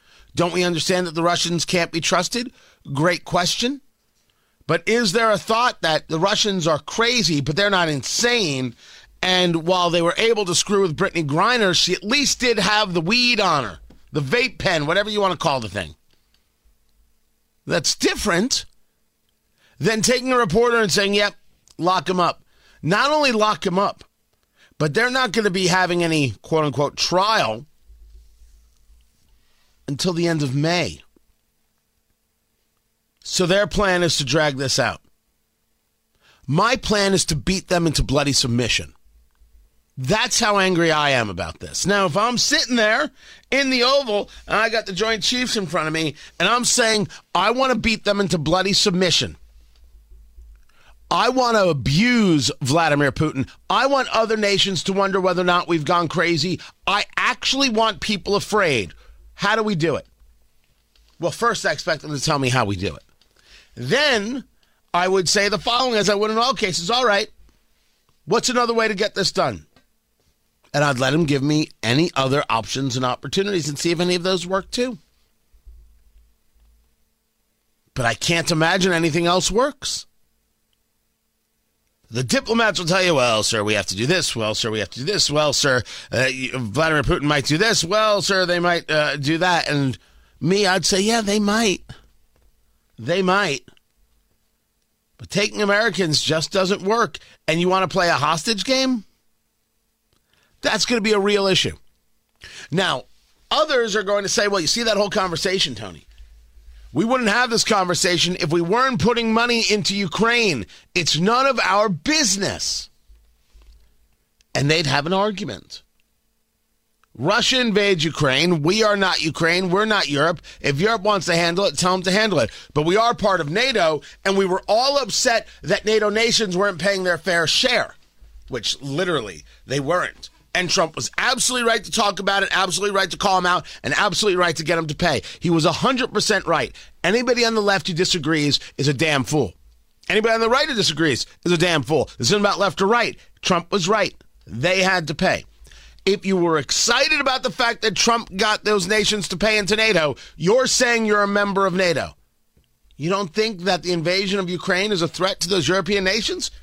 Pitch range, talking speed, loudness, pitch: 150-210 Hz, 180 wpm, -19 LUFS, 185 Hz